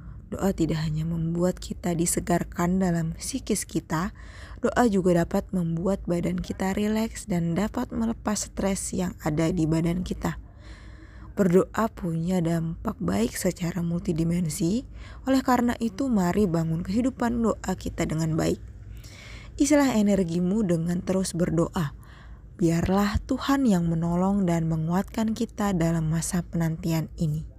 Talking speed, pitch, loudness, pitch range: 125 wpm, 175 Hz, -26 LUFS, 165-205 Hz